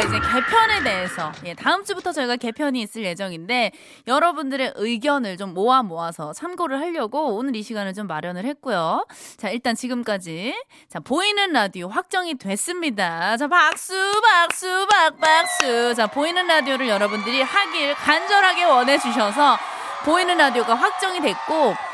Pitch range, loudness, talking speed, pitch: 215-340 Hz, -20 LUFS, 340 characters per minute, 270 Hz